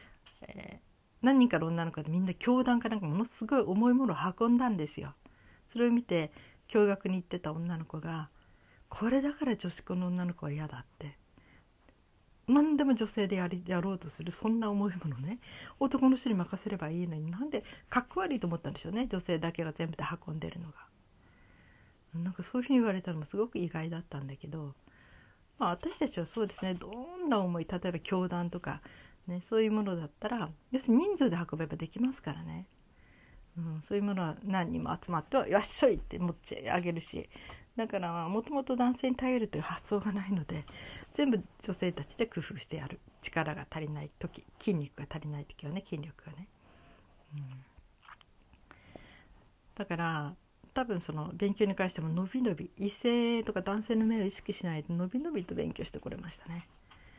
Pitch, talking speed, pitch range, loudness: 180 Hz, 355 characters per minute, 155-220 Hz, -33 LUFS